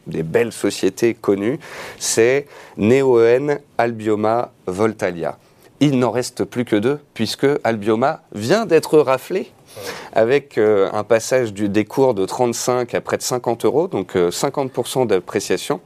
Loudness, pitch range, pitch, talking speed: -18 LUFS, 110-145 Hz, 125 Hz, 135 wpm